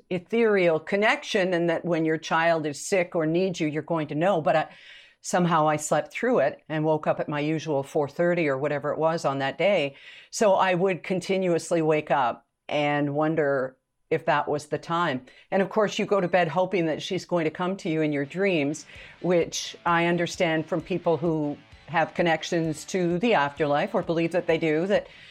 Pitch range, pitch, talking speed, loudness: 150-180 Hz, 165 Hz, 200 wpm, -25 LUFS